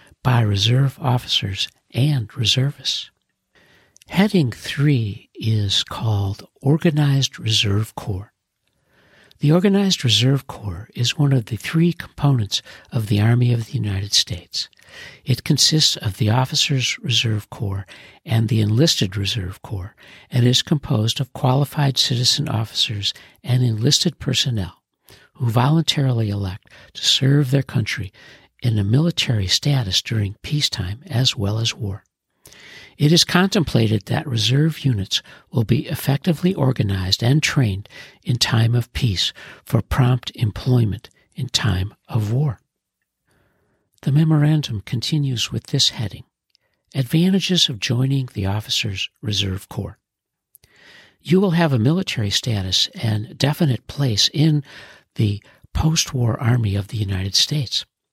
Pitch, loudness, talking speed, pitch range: 125 Hz, -19 LUFS, 125 wpm, 105-145 Hz